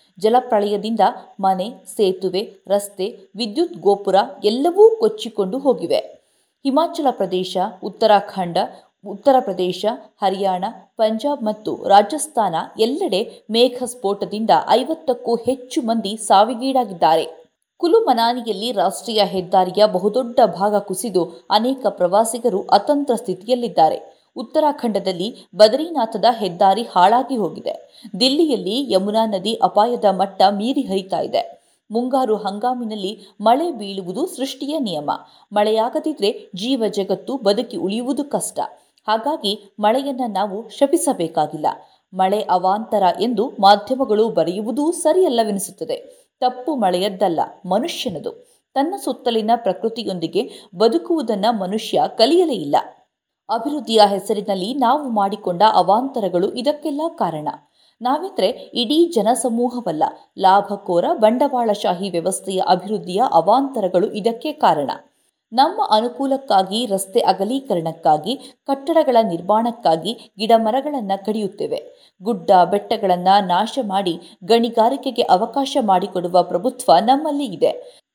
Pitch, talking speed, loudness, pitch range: 220 Hz, 90 wpm, -19 LUFS, 195-260 Hz